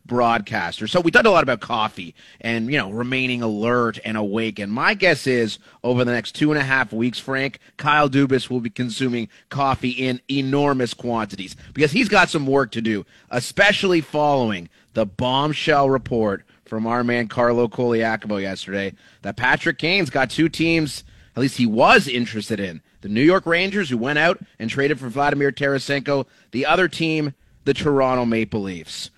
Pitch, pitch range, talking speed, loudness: 125 Hz, 115-145 Hz, 175 wpm, -20 LUFS